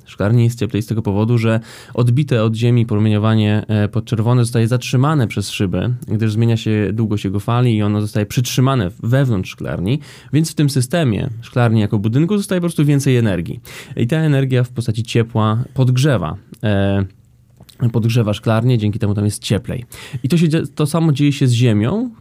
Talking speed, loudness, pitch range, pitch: 170 wpm, -17 LUFS, 110-135 Hz, 120 Hz